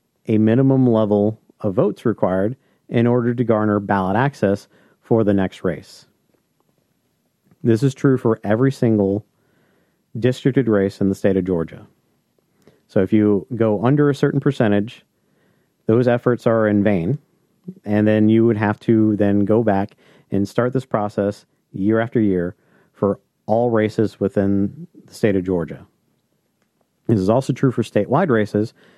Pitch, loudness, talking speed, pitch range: 110 Hz, -19 LUFS, 150 wpm, 100-125 Hz